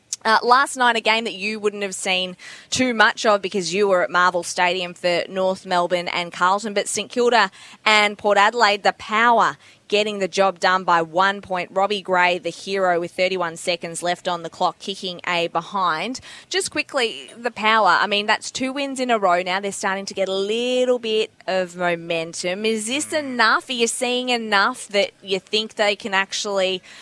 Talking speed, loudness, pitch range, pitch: 195 wpm, -20 LUFS, 180-220 Hz, 200 Hz